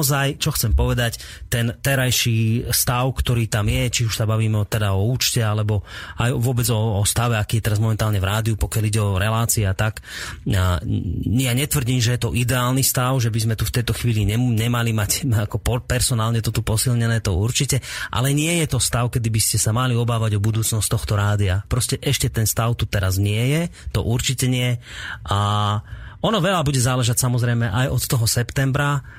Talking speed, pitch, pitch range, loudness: 190 wpm, 115 Hz, 110-125 Hz, -20 LUFS